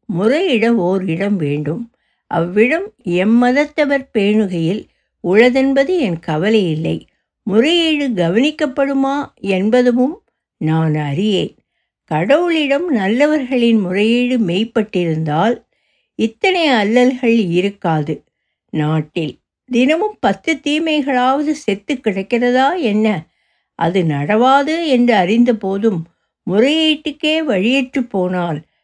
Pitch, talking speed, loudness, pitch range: 230 Hz, 75 wpm, -15 LUFS, 185-275 Hz